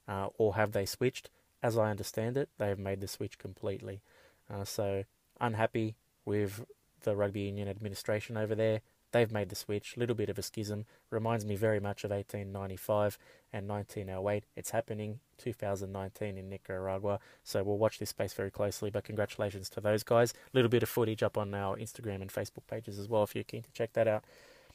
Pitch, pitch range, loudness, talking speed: 105 Hz, 100-110 Hz, -35 LUFS, 190 wpm